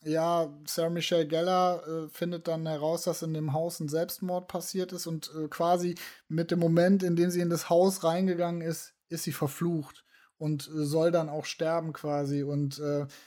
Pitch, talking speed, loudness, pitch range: 165 Hz, 190 wpm, -30 LUFS, 155-175 Hz